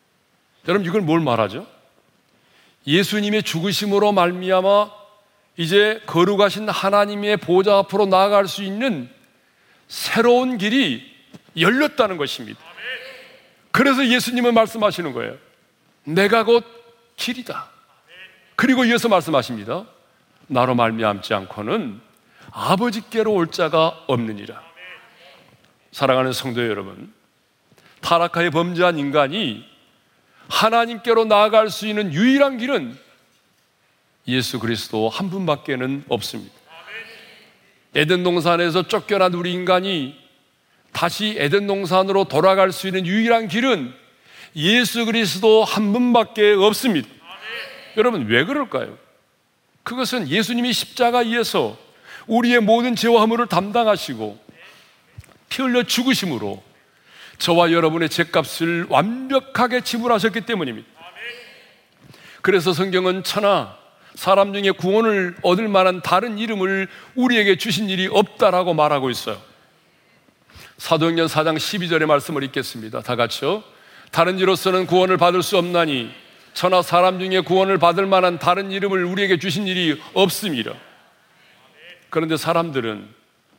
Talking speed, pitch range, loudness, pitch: 275 characters per minute, 170-220 Hz, -19 LUFS, 190 Hz